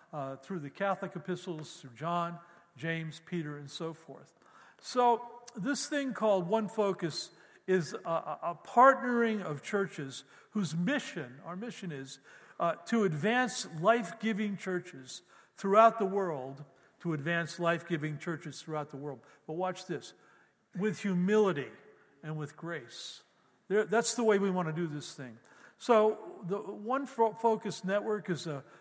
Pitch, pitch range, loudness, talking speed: 180 Hz, 155-215 Hz, -32 LUFS, 150 wpm